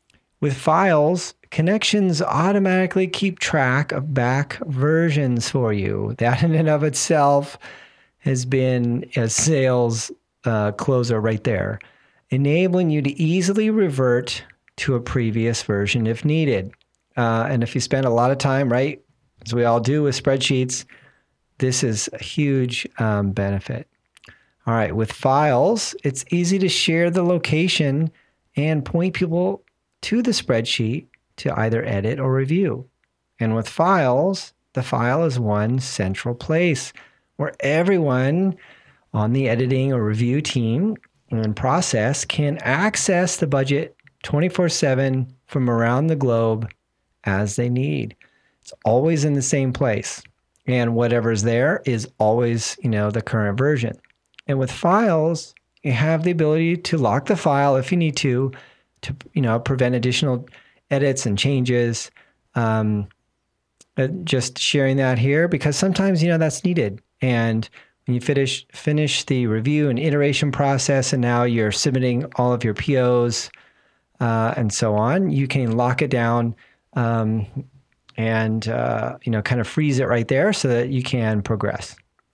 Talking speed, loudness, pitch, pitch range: 145 wpm, -20 LUFS, 130 Hz, 120-155 Hz